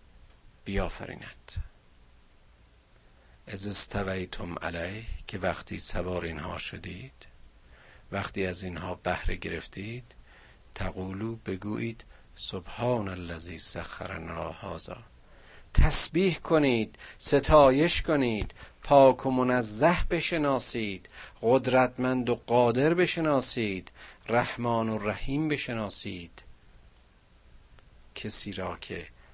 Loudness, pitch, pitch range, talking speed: -29 LUFS, 100 Hz, 85-120 Hz, 80 wpm